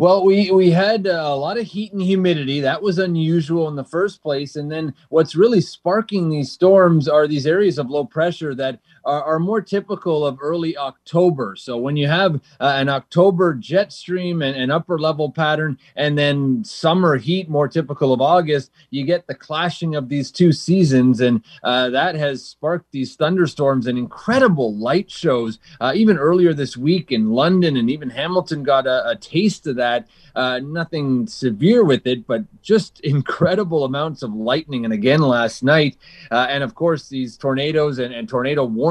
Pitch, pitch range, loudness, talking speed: 155 Hz, 135-175 Hz, -18 LUFS, 185 wpm